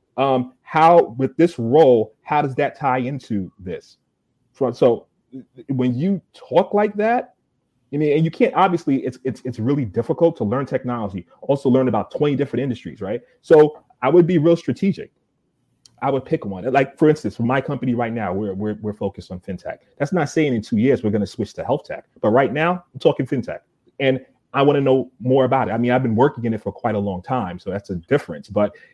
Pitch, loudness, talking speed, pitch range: 130 Hz, -20 LUFS, 220 wpm, 115-145 Hz